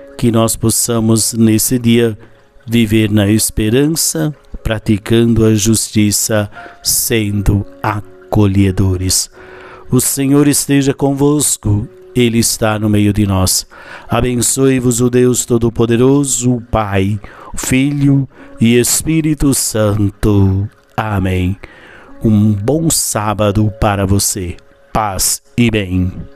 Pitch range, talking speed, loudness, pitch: 105-125 Hz, 95 wpm, -13 LUFS, 115 Hz